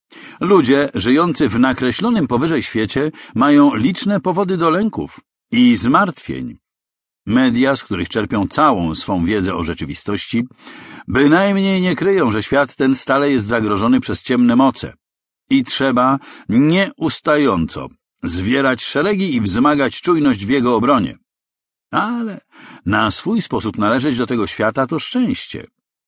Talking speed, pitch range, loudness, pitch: 125 wpm, 120-195 Hz, -16 LUFS, 140 Hz